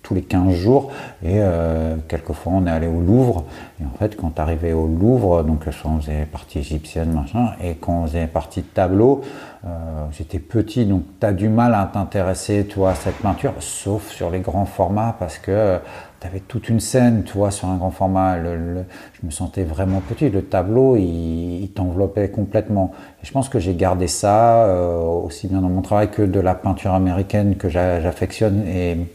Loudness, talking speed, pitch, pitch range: -19 LUFS, 205 wpm, 95 Hz, 85-105 Hz